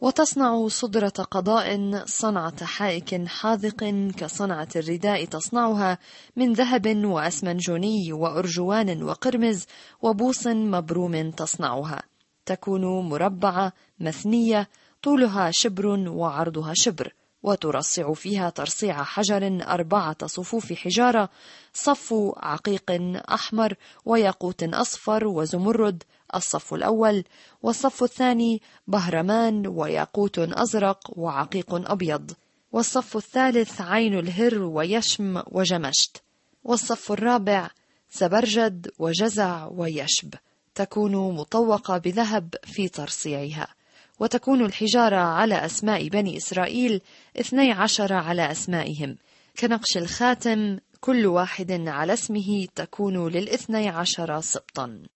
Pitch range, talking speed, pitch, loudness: 175-225 Hz, 90 wpm, 200 Hz, -24 LUFS